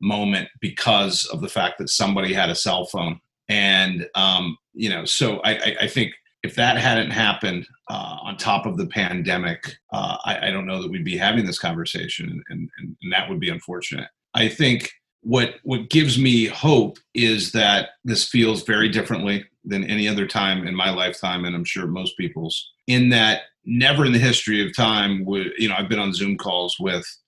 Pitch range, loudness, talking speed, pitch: 100-125 Hz, -20 LUFS, 200 wpm, 110 Hz